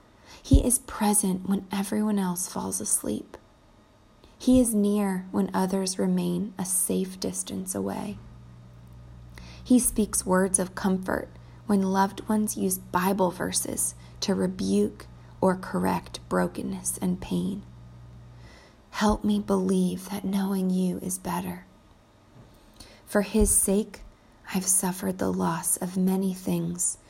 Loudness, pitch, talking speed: -26 LUFS, 185 Hz, 120 wpm